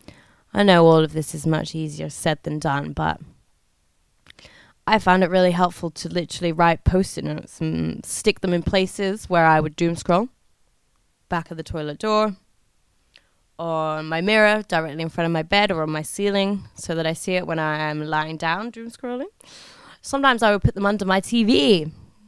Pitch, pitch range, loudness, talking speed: 170 Hz, 155-200 Hz, -21 LUFS, 190 wpm